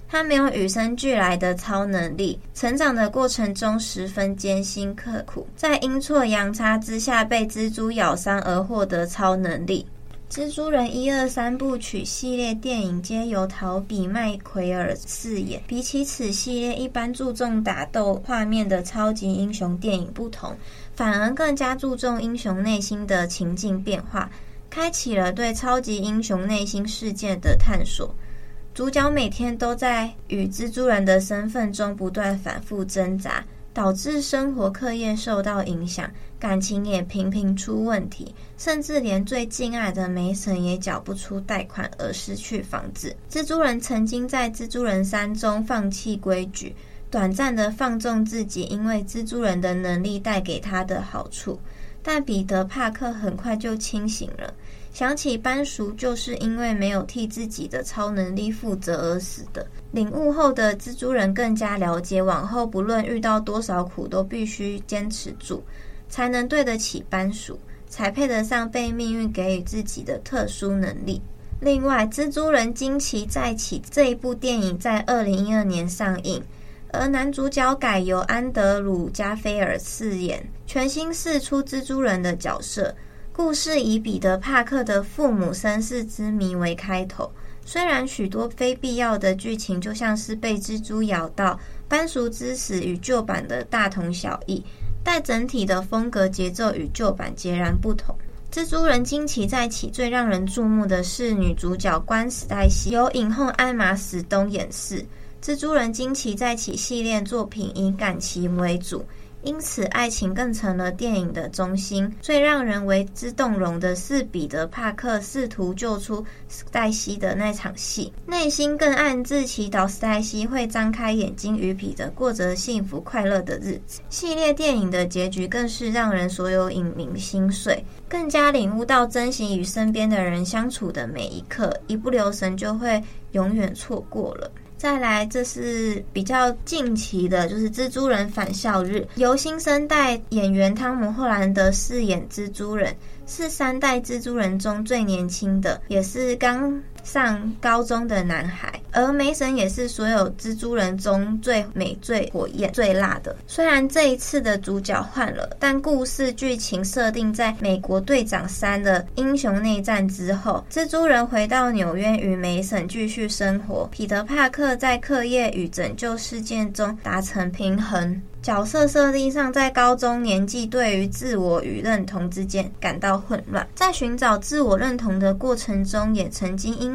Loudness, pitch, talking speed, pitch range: -23 LUFS, 220 Hz, 245 characters per minute, 195-250 Hz